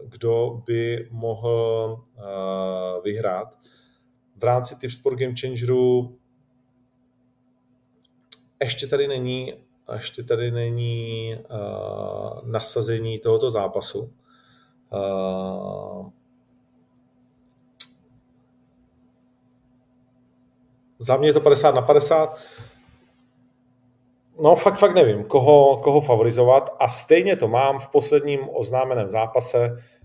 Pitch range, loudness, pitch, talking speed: 120-125 Hz, -21 LUFS, 125 Hz, 85 wpm